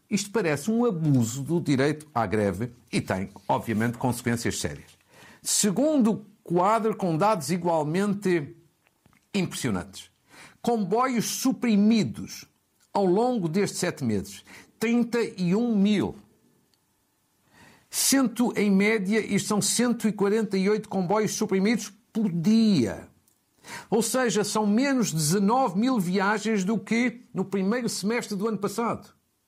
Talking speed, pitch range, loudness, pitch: 110 wpm, 170-225 Hz, -25 LUFS, 205 Hz